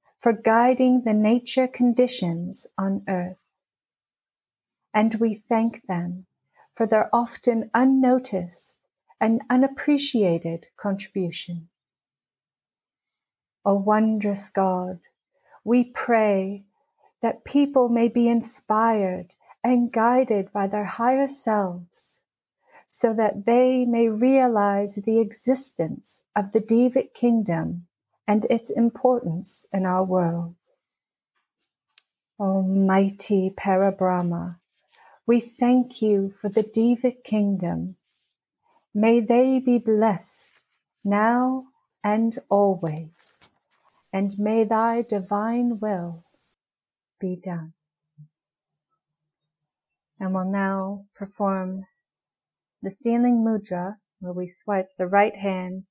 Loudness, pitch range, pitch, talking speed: -23 LUFS, 185-235 Hz, 210 Hz, 95 wpm